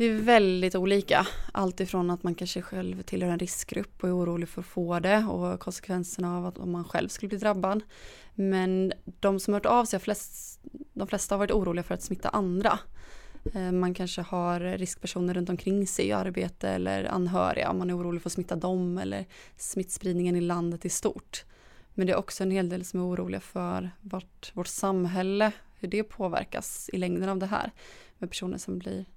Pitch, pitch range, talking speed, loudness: 185 Hz, 175-195 Hz, 195 wpm, -29 LUFS